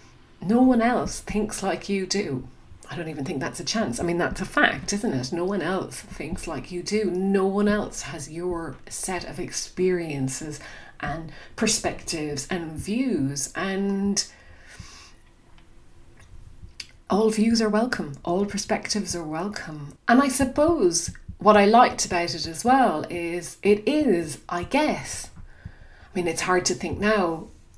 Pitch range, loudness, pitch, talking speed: 165-215 Hz, -24 LUFS, 190 Hz, 155 wpm